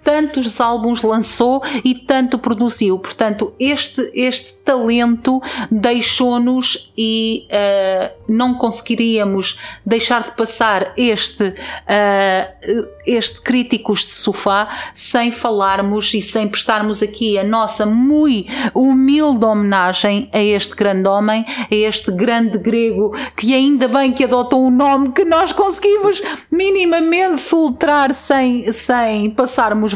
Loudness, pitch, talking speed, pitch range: -15 LUFS, 235 Hz, 115 wpm, 215-260 Hz